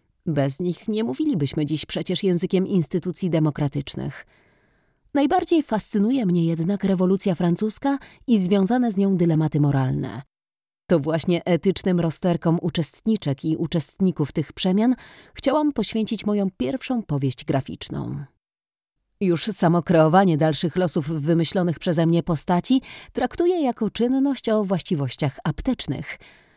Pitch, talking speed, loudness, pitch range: 180 Hz, 115 wpm, -22 LUFS, 160-215 Hz